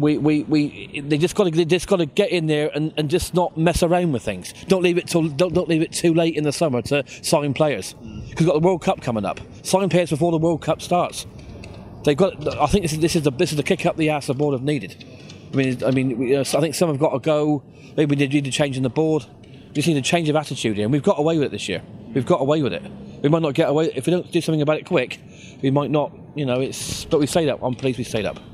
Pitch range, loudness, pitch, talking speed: 135-170 Hz, -21 LUFS, 150 Hz, 305 wpm